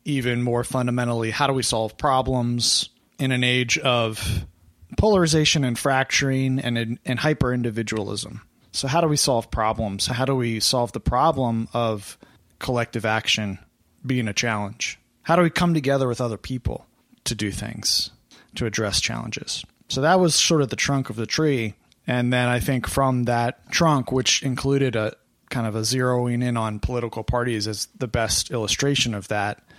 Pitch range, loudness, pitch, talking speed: 110-135 Hz, -22 LUFS, 120 Hz, 170 wpm